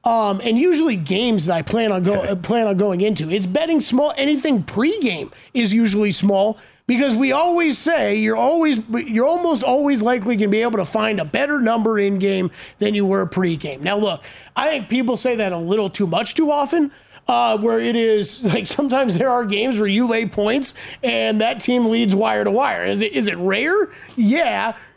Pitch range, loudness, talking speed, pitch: 205-260 Hz, -18 LUFS, 205 wpm, 225 Hz